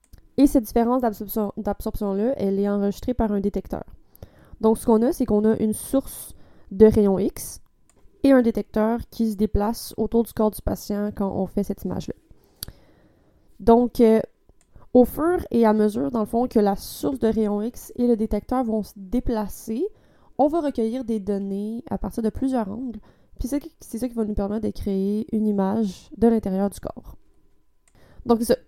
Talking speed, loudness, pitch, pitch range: 185 wpm, -23 LUFS, 220 Hz, 205-240 Hz